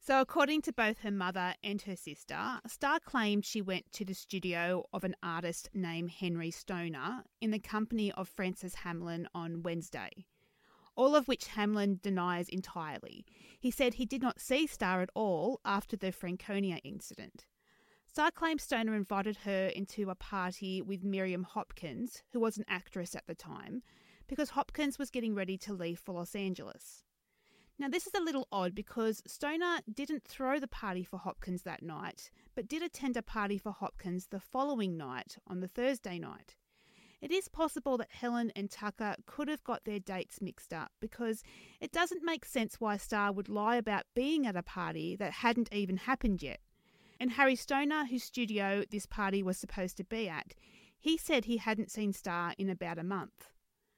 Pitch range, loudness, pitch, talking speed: 185-250 Hz, -36 LUFS, 205 Hz, 180 wpm